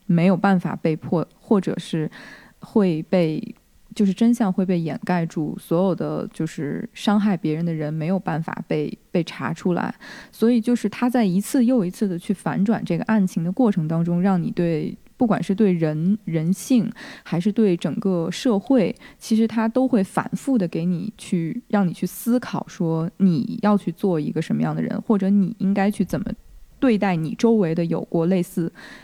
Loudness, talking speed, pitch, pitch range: -22 LUFS, 260 characters per minute, 195 Hz, 175-220 Hz